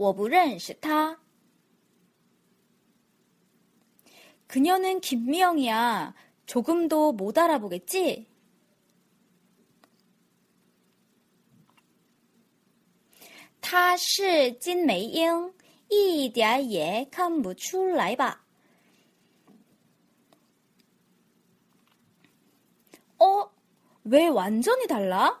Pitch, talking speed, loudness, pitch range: 255 Hz, 100 characters per minute, -25 LUFS, 215-340 Hz